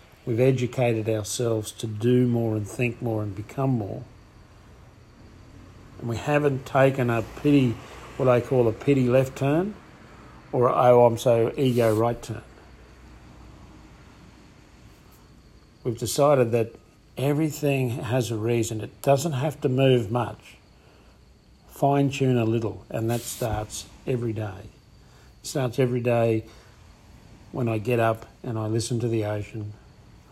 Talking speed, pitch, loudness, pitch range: 135 wpm, 115 Hz, -24 LUFS, 110-130 Hz